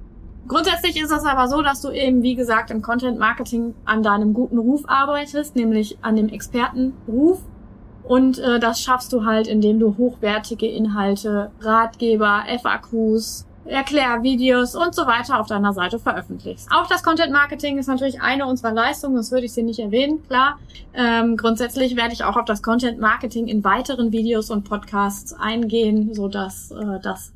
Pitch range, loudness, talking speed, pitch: 220-260 Hz, -20 LUFS, 165 wpm, 235 Hz